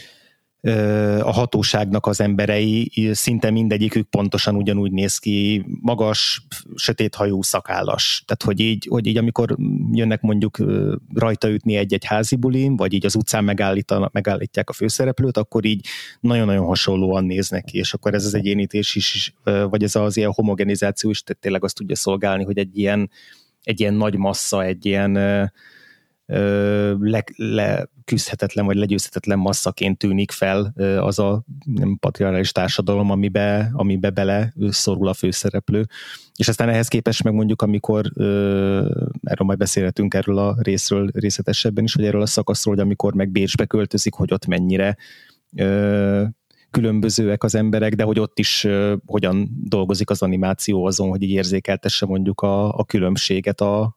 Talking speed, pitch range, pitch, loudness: 150 wpm, 100-110 Hz, 105 Hz, -20 LUFS